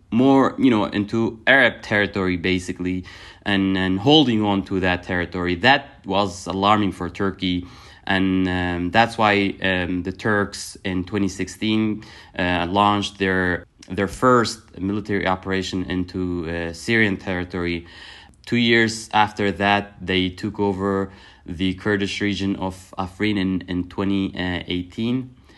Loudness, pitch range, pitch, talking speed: -21 LUFS, 90-105 Hz, 95 Hz, 125 wpm